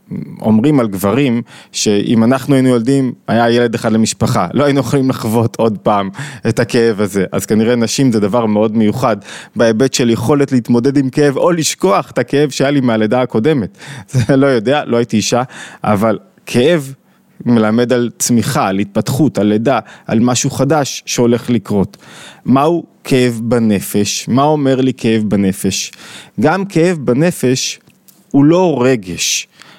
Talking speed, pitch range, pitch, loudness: 150 wpm, 110-140 Hz, 120 Hz, -13 LUFS